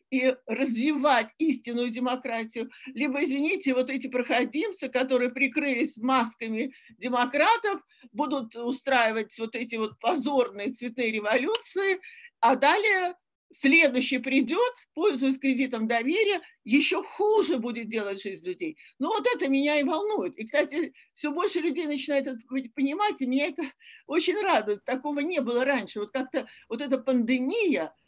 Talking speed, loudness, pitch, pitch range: 135 wpm, -27 LUFS, 275 Hz, 245-335 Hz